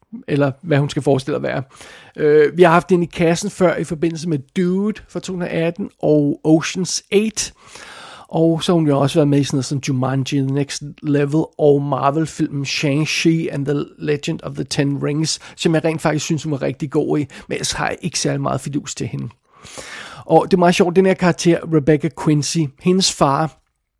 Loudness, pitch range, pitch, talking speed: -18 LUFS, 145-175 Hz, 155 Hz, 210 wpm